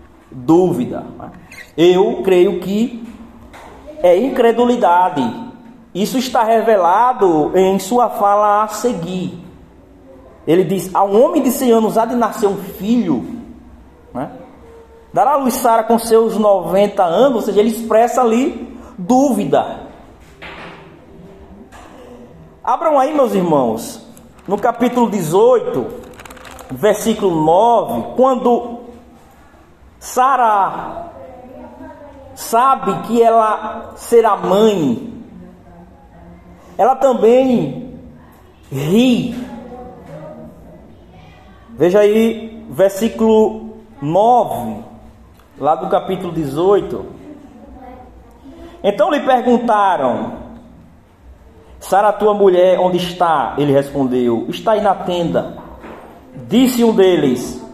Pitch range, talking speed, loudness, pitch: 180-245 Hz, 85 wpm, -14 LUFS, 215 Hz